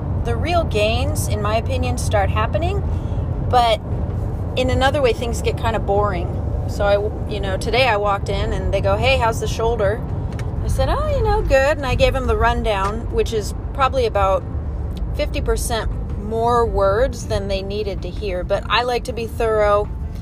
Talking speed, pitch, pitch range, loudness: 185 wpm, 100 Hz, 90-115 Hz, -20 LUFS